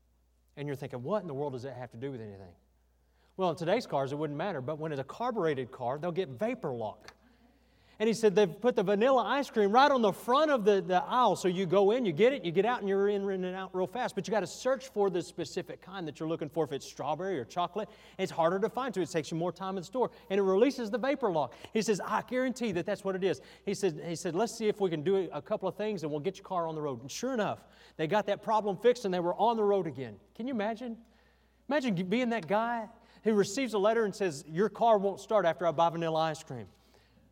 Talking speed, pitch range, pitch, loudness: 275 wpm, 160-220 Hz, 195 Hz, -31 LUFS